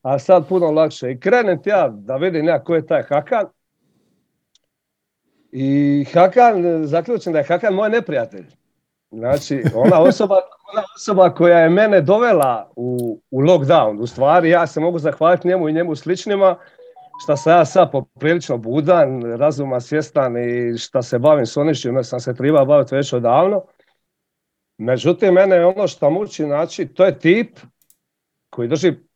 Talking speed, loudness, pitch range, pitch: 160 wpm, -16 LUFS, 135-185 Hz, 165 Hz